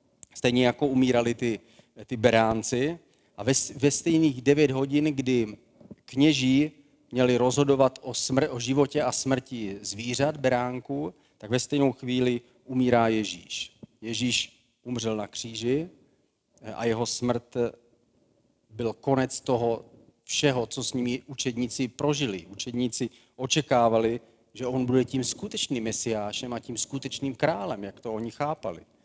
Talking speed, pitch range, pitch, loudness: 130 wpm, 115-135 Hz, 125 Hz, -27 LUFS